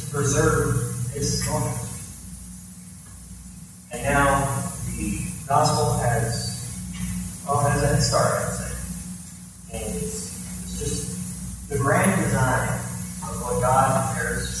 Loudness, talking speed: -23 LUFS, 105 wpm